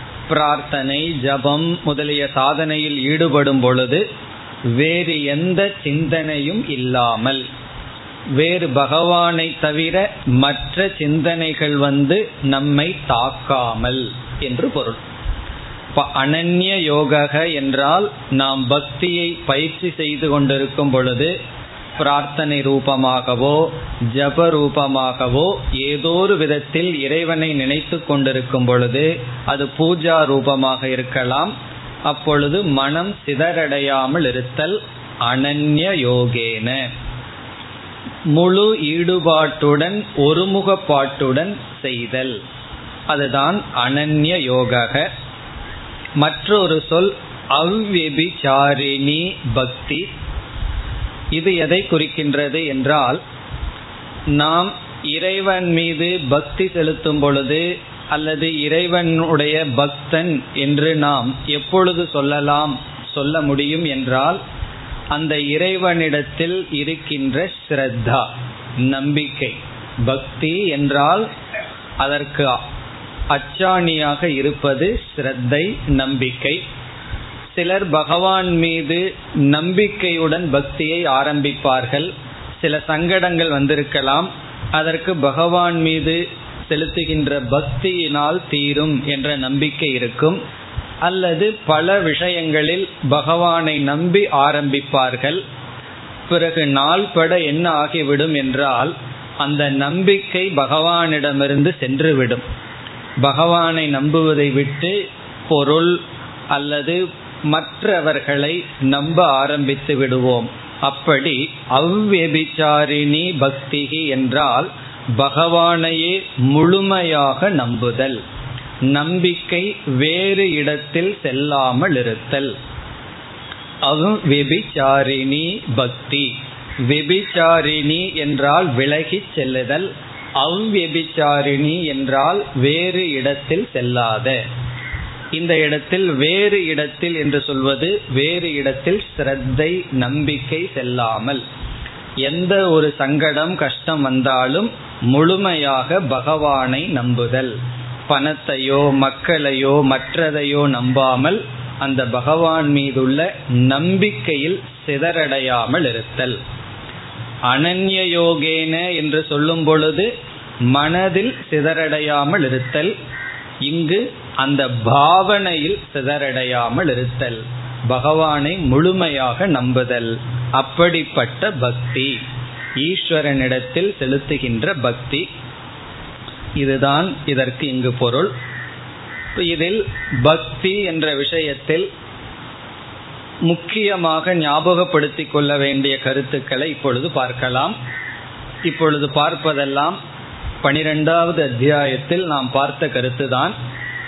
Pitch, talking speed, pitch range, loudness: 145 Hz, 70 wpm, 135-165 Hz, -17 LUFS